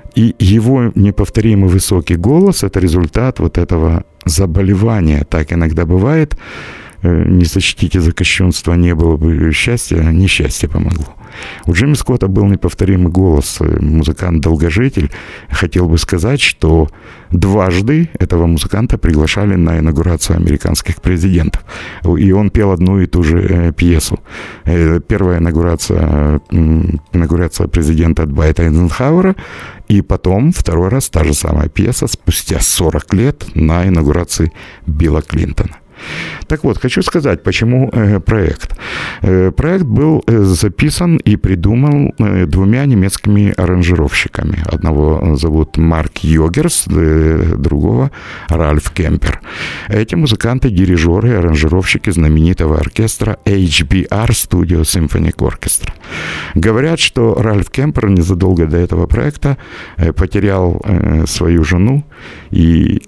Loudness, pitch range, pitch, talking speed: -12 LUFS, 80-105 Hz, 90 Hz, 110 wpm